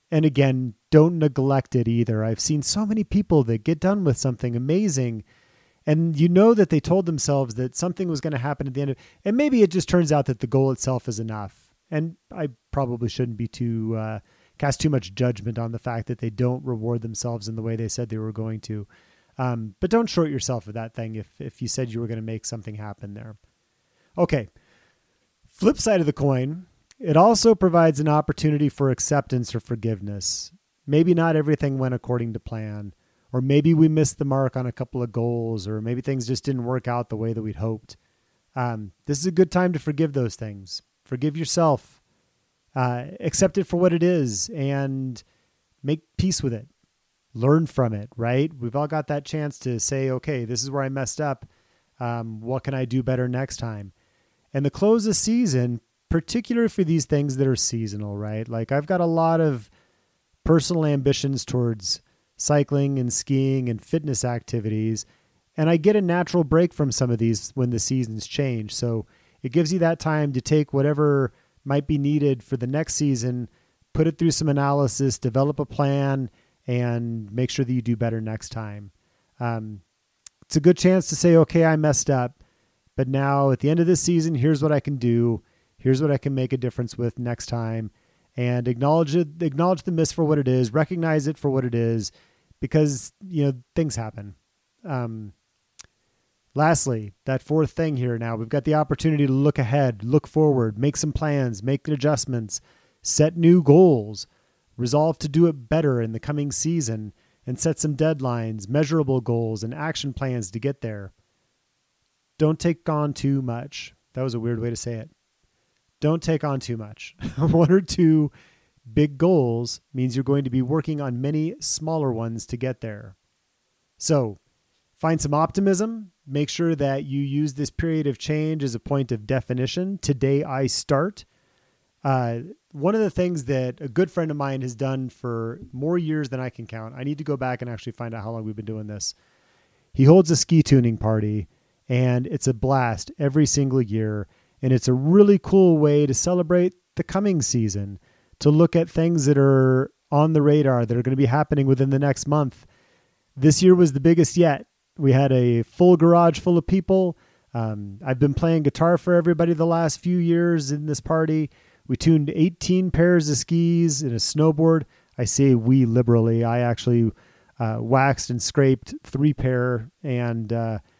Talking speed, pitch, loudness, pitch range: 195 wpm, 135 Hz, -22 LUFS, 120-155 Hz